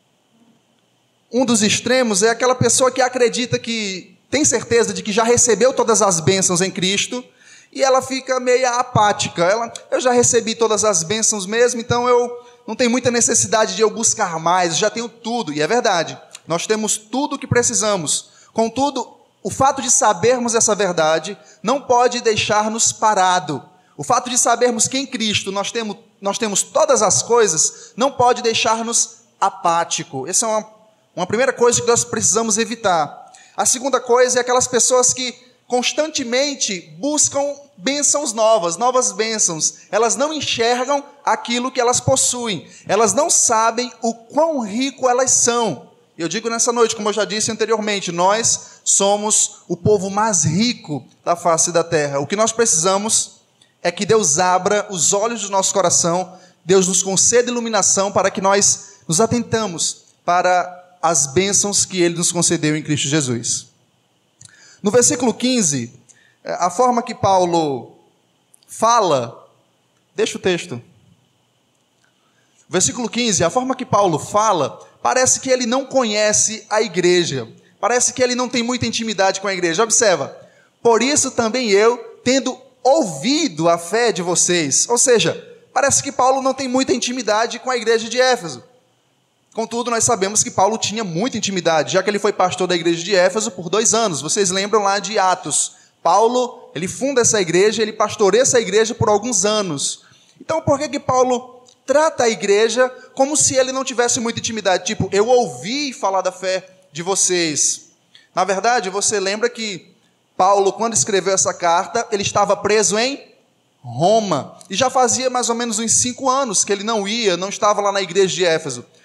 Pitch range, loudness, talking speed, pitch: 190-245 Hz, -17 LUFS, 165 wpm, 220 Hz